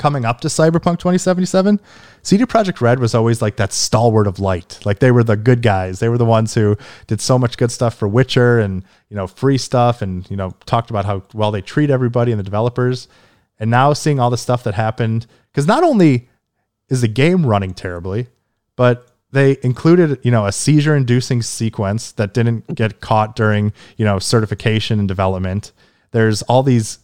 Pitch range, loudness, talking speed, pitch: 105-130 Hz, -16 LUFS, 195 wpm, 115 Hz